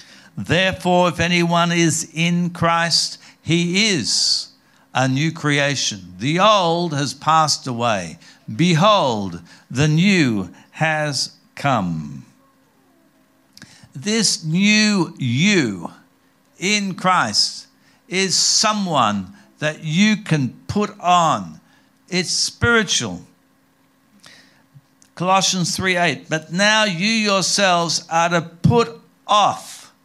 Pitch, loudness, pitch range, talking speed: 170 Hz, -18 LUFS, 145-190 Hz, 90 wpm